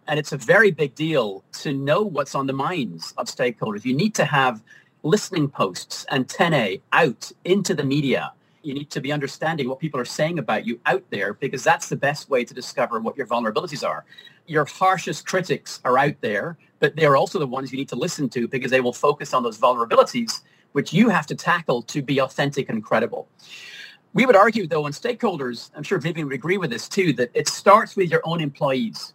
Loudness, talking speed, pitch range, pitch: -22 LUFS, 215 wpm, 140-190 Hz, 150 Hz